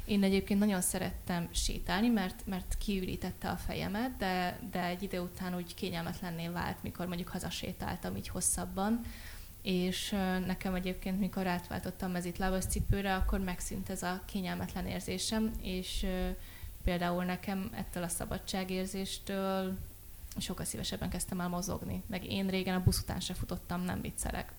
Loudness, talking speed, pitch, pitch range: -36 LUFS, 145 wpm, 185 Hz, 175-195 Hz